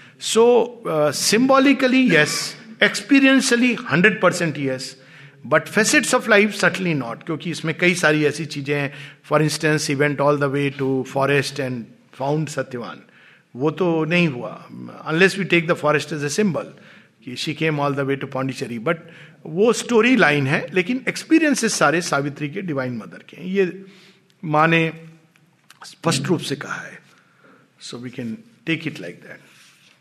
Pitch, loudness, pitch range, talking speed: 160 Hz, -19 LUFS, 145-190 Hz, 160 wpm